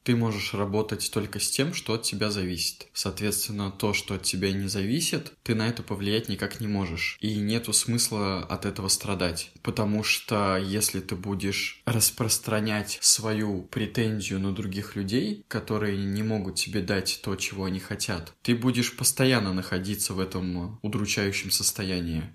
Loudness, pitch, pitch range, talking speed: -27 LUFS, 105 Hz, 95-110 Hz, 155 wpm